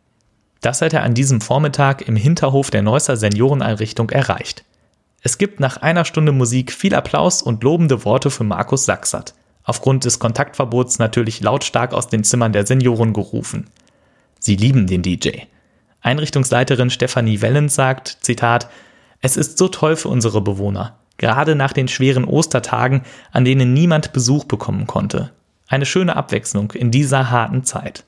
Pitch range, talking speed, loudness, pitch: 115-140 Hz, 150 wpm, -16 LUFS, 130 Hz